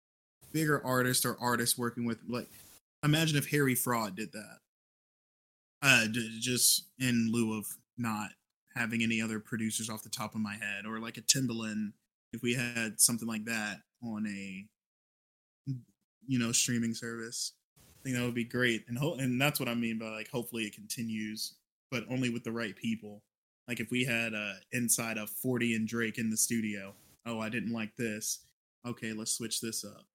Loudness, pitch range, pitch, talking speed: -32 LUFS, 110-120 Hz, 115 Hz, 185 wpm